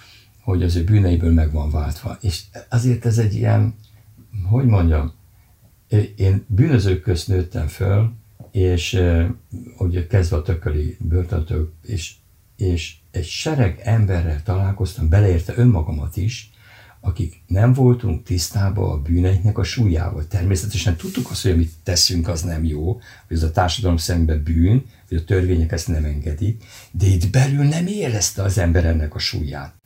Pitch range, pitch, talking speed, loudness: 85-110 Hz, 95 Hz, 150 wpm, -20 LUFS